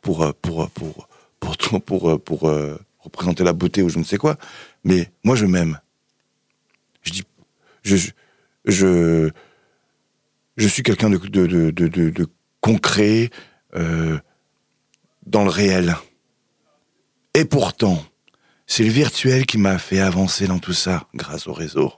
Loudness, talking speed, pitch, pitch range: -19 LUFS, 145 wpm, 95 Hz, 85-100 Hz